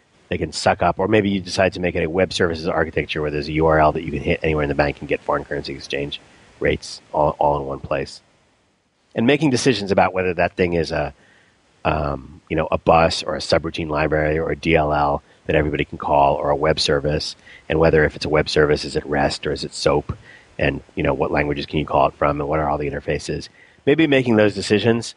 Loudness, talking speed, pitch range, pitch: -20 LUFS, 240 wpm, 75-90 Hz, 80 Hz